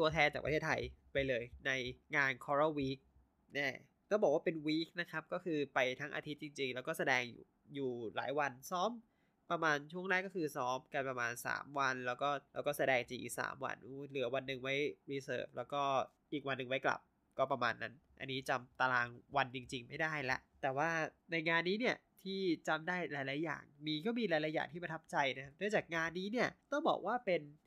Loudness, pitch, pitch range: -38 LUFS, 145 Hz, 130-165 Hz